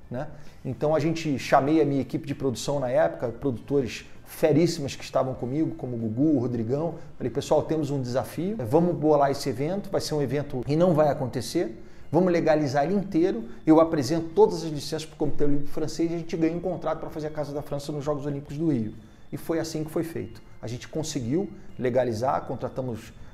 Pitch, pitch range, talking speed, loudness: 145 Hz, 130-160 Hz, 210 wpm, -26 LUFS